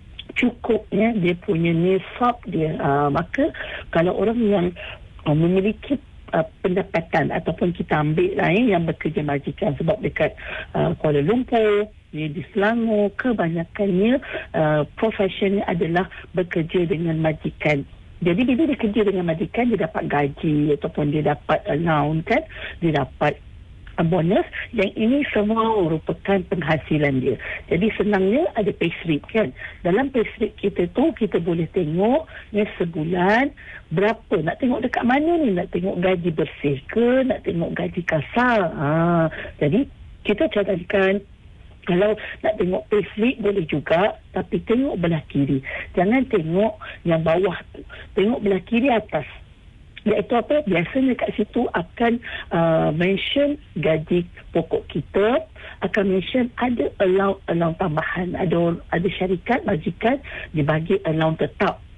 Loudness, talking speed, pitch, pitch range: -21 LUFS, 130 wpm, 195 Hz, 165-220 Hz